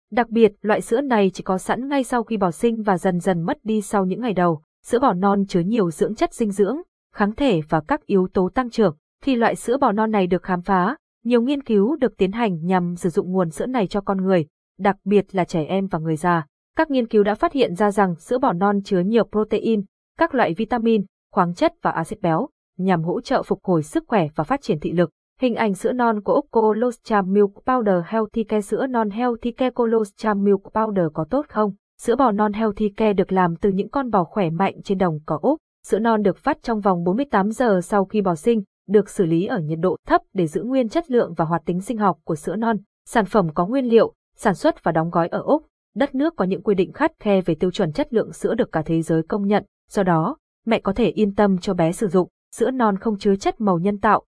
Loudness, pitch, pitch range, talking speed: -21 LUFS, 205 Hz, 185-235 Hz, 250 wpm